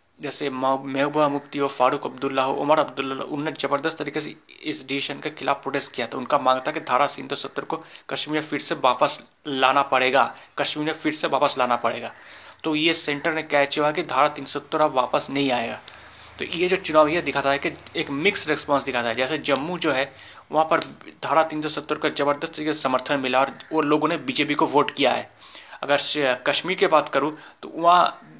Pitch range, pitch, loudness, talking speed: 135-155 Hz, 145 Hz, -23 LUFS, 205 wpm